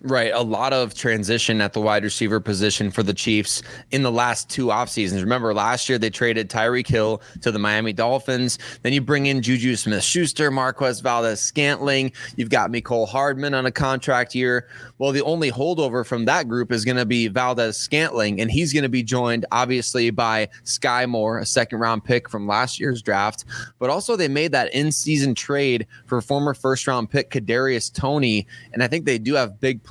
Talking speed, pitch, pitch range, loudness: 190 wpm, 125 Hz, 110-135 Hz, -21 LUFS